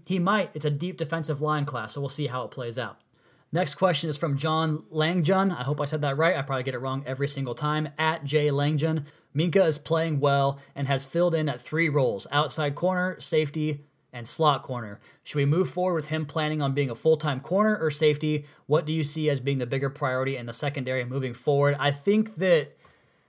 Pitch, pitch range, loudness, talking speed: 150 Hz, 140-160 Hz, -26 LUFS, 225 wpm